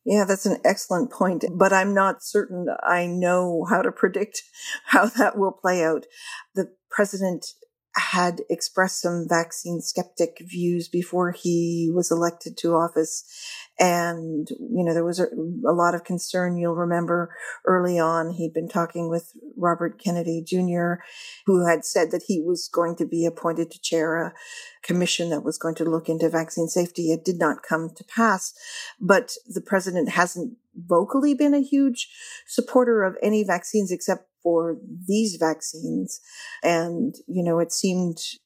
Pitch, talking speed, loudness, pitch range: 175 Hz, 160 wpm, -23 LUFS, 170-200 Hz